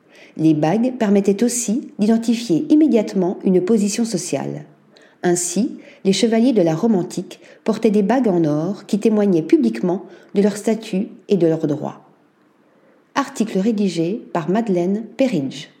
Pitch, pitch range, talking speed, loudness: 205 Hz, 180-235 Hz, 135 wpm, -18 LUFS